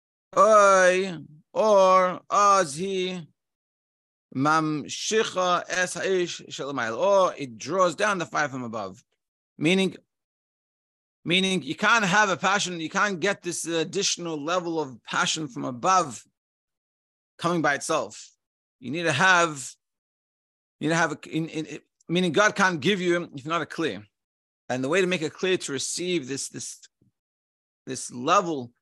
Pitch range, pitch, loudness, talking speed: 145-185 Hz, 170 Hz, -24 LUFS, 135 wpm